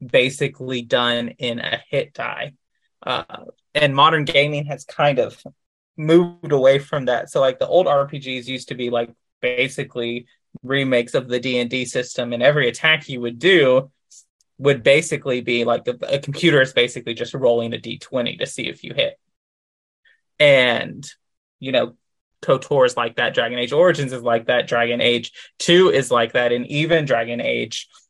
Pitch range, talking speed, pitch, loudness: 120-140 Hz, 175 wpm, 130 Hz, -19 LUFS